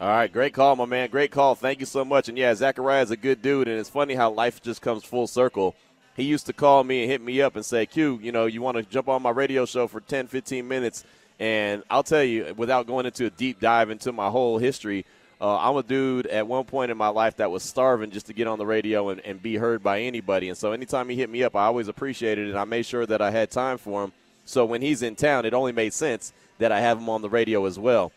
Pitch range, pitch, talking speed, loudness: 110-130 Hz, 120 Hz, 280 wpm, -24 LUFS